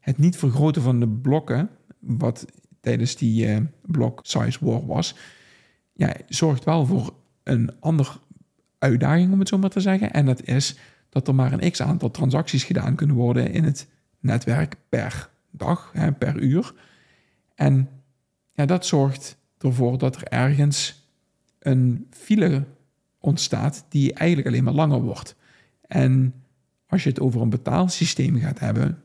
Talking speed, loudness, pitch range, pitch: 155 wpm, -22 LUFS, 130-160 Hz, 140 Hz